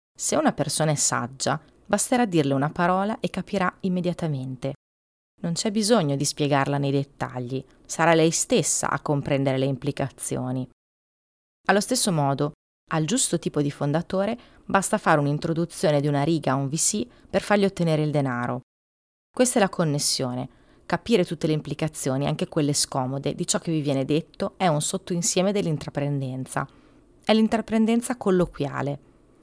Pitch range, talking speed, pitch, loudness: 140-190 Hz, 145 wpm, 155 Hz, -24 LUFS